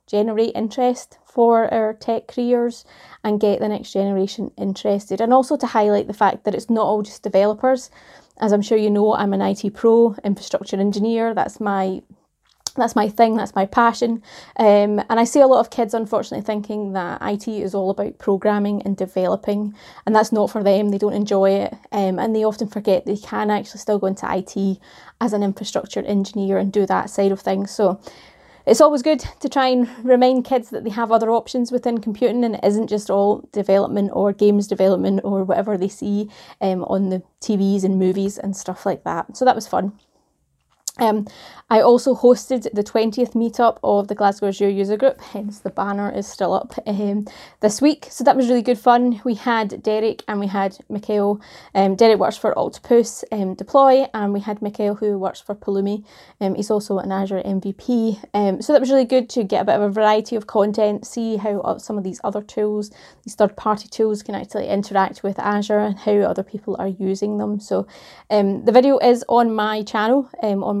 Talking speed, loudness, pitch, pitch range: 205 wpm, -19 LUFS, 210 Hz, 200-230 Hz